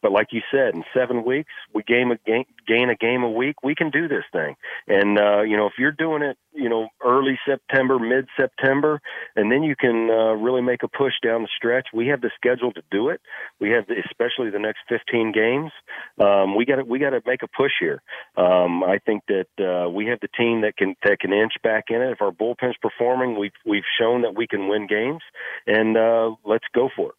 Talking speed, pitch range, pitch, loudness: 240 wpm, 105-130 Hz, 115 Hz, -21 LUFS